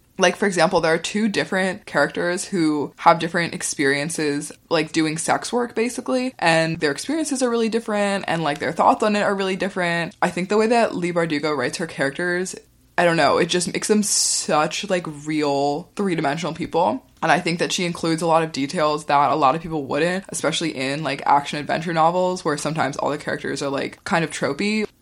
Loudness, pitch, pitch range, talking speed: -21 LUFS, 170 Hz, 155-195 Hz, 205 wpm